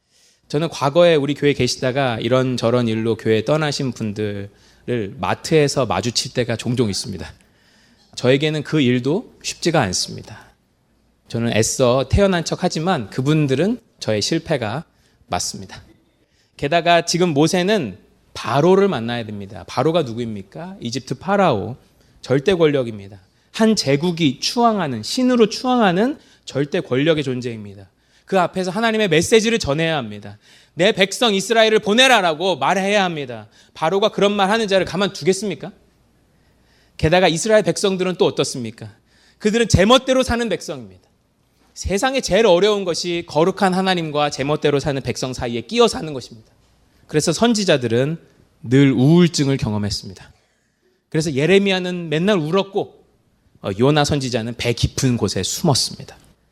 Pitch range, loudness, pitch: 120-190 Hz, -18 LUFS, 145 Hz